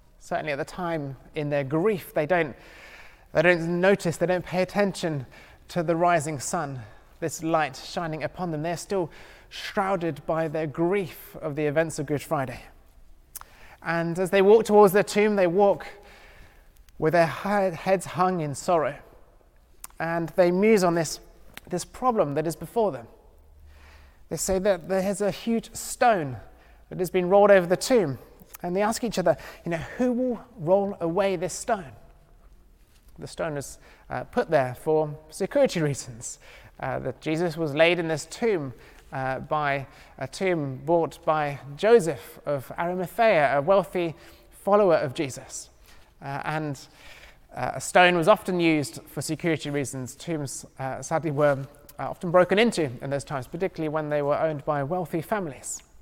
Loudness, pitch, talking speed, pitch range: -25 LUFS, 165 Hz, 160 wpm, 145-185 Hz